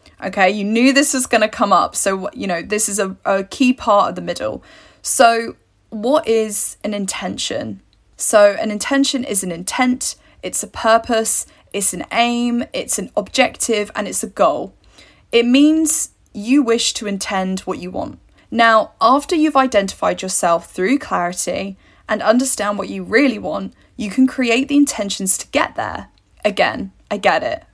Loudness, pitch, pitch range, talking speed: -17 LUFS, 220 Hz, 195-260 Hz, 170 wpm